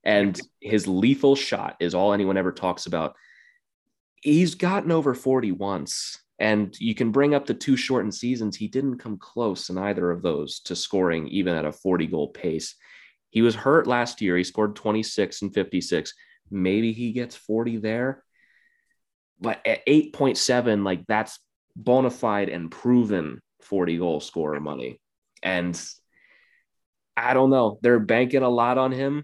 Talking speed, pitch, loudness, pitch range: 160 wpm, 115 Hz, -24 LUFS, 100-135 Hz